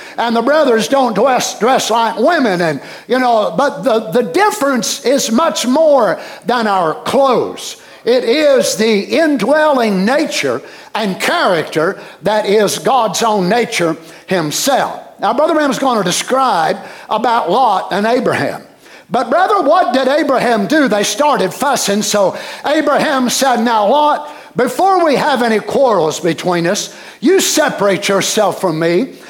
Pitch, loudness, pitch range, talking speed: 250 Hz, -13 LUFS, 210-295 Hz, 145 wpm